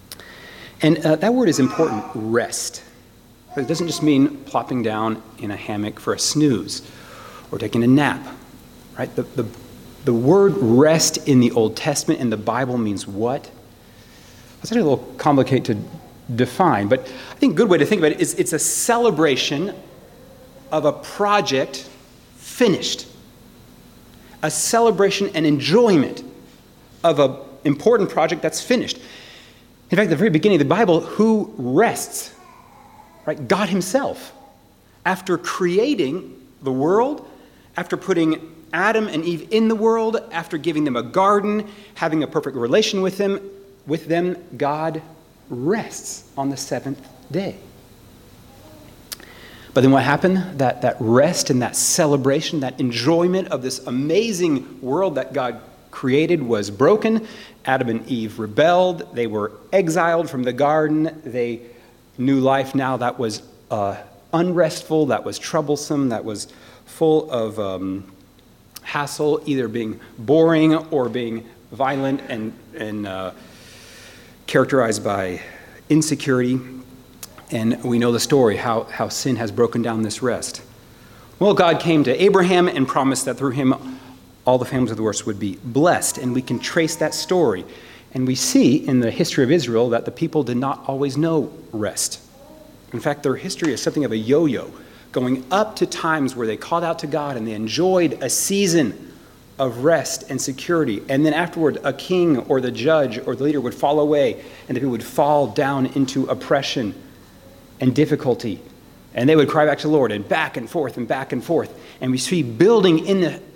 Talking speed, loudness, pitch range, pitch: 160 wpm, -20 LUFS, 120-165 Hz, 140 Hz